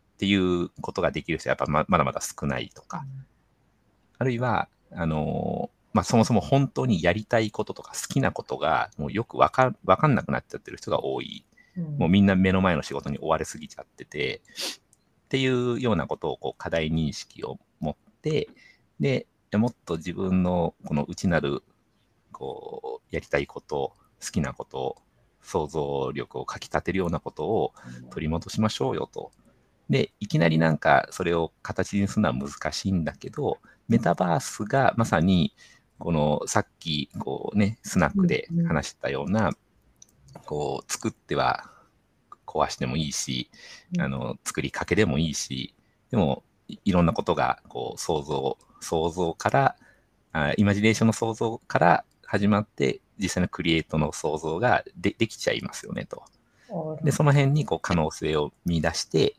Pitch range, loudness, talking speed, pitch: 80-115 Hz, -26 LUFS, 320 characters per minute, 95 Hz